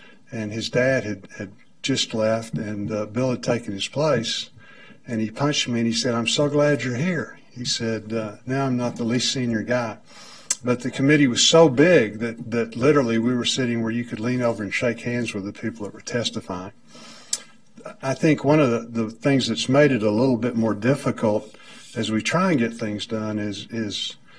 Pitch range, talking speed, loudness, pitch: 110-130 Hz, 210 wpm, -22 LUFS, 115 Hz